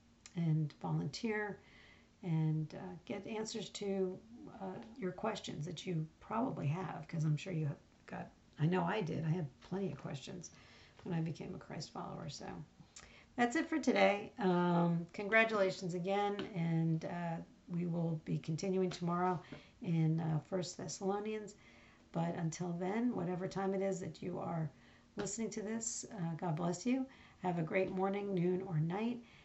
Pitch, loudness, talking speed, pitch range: 185 Hz, -38 LUFS, 160 wpm, 165-200 Hz